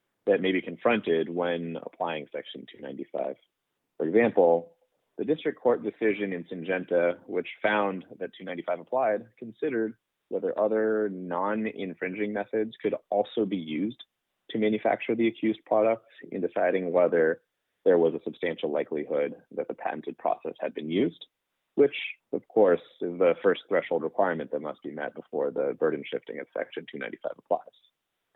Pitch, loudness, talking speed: 110 Hz, -28 LUFS, 150 wpm